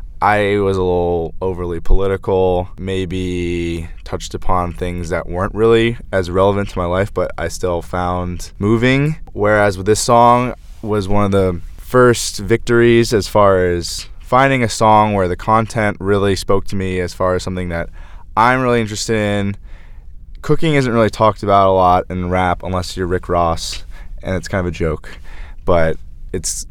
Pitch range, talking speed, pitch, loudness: 85-105 Hz, 170 wpm, 95 Hz, -16 LUFS